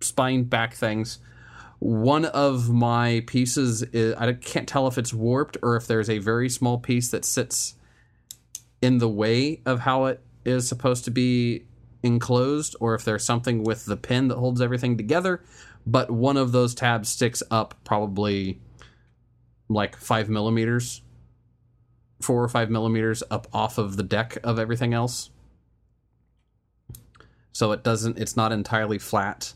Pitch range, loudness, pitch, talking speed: 110-125 Hz, -24 LUFS, 120 Hz, 150 wpm